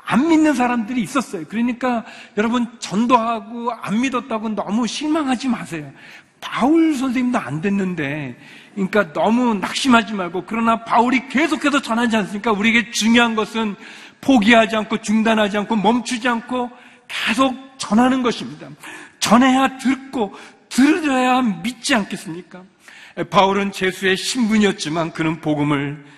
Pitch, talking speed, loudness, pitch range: 230 Hz, 325 characters per minute, -18 LUFS, 200-250 Hz